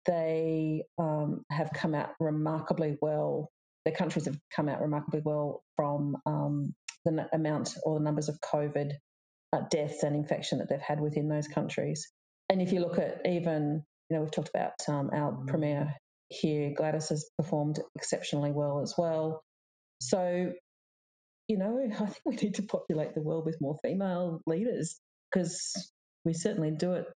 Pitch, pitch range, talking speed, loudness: 155 Hz, 150-170 Hz, 170 wpm, -32 LUFS